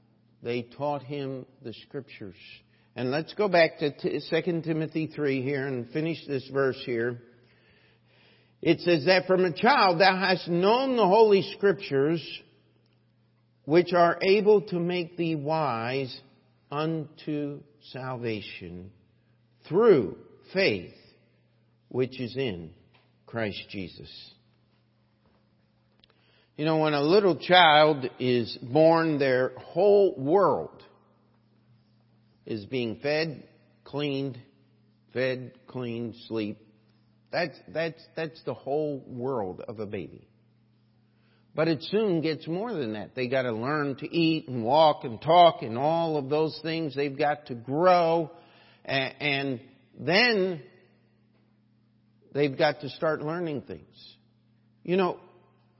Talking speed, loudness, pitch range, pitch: 120 wpm, -26 LUFS, 115-160 Hz, 135 Hz